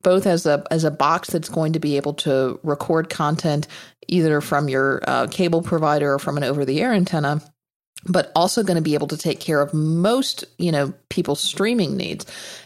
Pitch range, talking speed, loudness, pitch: 145-175 Hz, 205 wpm, -21 LUFS, 155 Hz